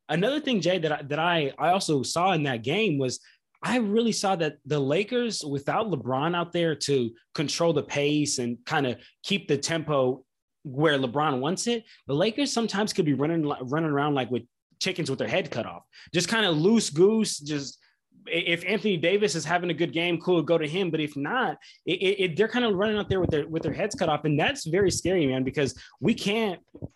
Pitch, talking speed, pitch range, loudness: 165 Hz, 220 wpm, 145-195 Hz, -26 LUFS